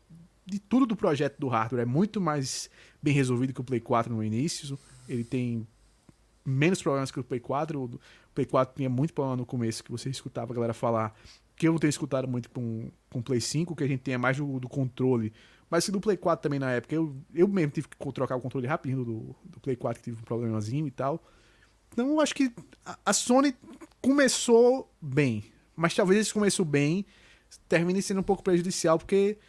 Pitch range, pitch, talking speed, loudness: 125-175 Hz, 140 Hz, 215 wpm, -28 LUFS